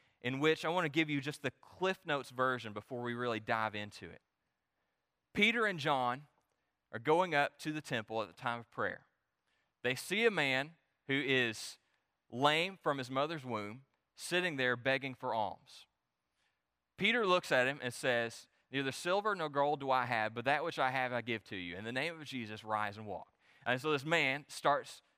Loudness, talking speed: -35 LUFS, 200 wpm